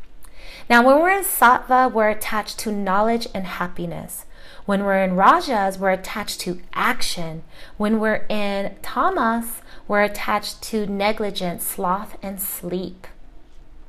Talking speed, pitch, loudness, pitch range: 130 wpm, 205 Hz, -20 LUFS, 190-225 Hz